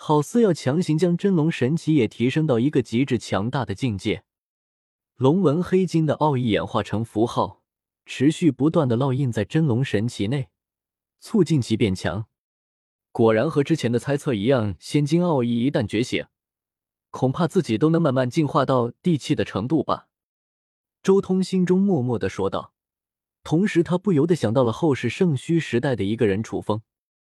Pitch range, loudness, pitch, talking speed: 110-160 Hz, -22 LUFS, 135 Hz, 260 characters per minute